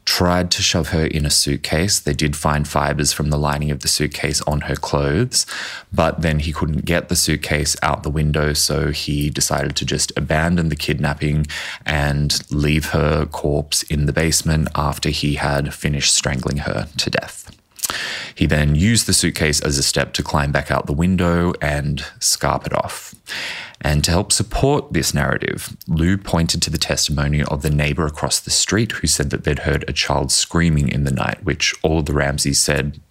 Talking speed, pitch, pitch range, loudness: 190 wpm, 75 Hz, 75-80 Hz, -18 LUFS